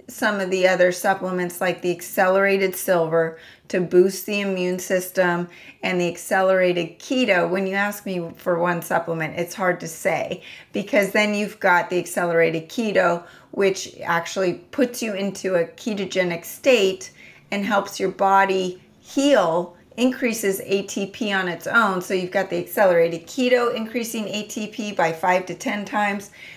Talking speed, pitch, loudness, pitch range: 150 wpm, 190 Hz, -22 LUFS, 175-205 Hz